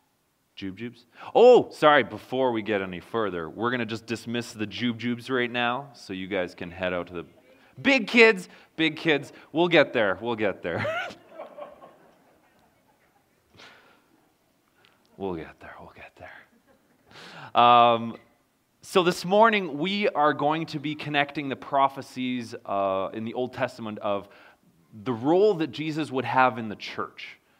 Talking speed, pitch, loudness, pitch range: 150 wpm, 125 Hz, -24 LUFS, 110-150 Hz